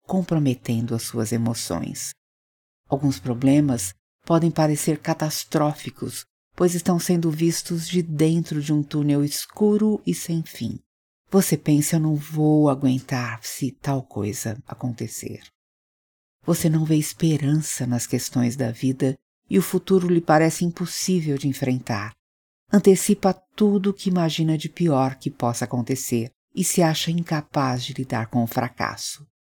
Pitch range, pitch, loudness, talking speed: 125-165 Hz, 145 Hz, -23 LUFS, 135 wpm